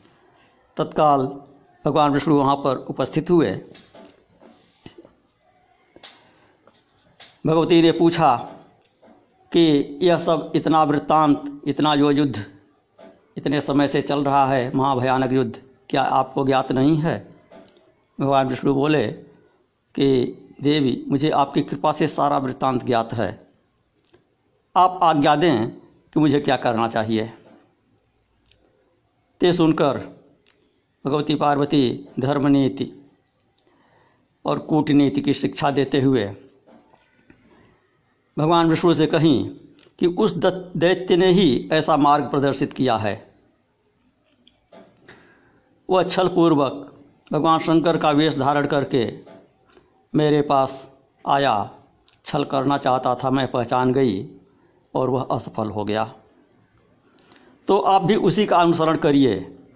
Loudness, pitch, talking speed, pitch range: -20 LUFS, 145 Hz, 110 wpm, 130-155 Hz